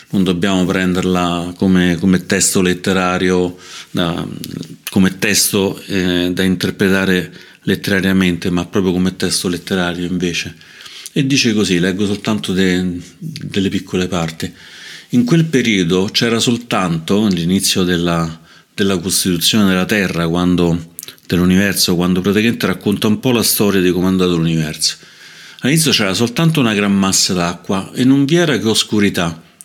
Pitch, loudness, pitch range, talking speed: 95 Hz, -15 LUFS, 90-100 Hz, 130 wpm